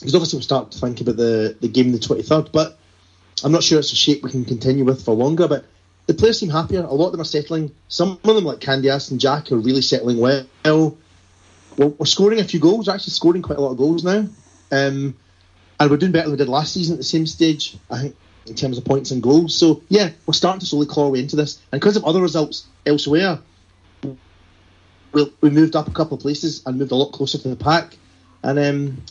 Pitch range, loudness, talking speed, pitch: 125-160 Hz, -18 LUFS, 250 wpm, 140 Hz